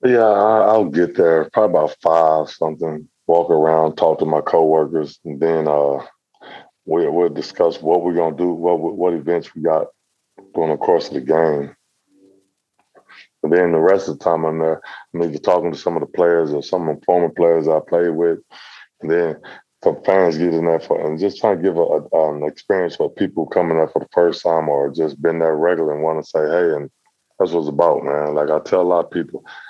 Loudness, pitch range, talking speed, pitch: -17 LUFS, 80-85 Hz, 220 wpm, 80 Hz